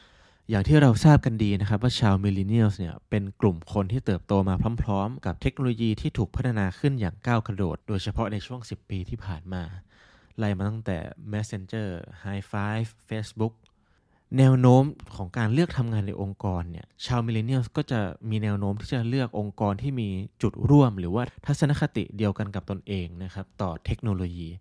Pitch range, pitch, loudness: 95-120 Hz, 105 Hz, -26 LUFS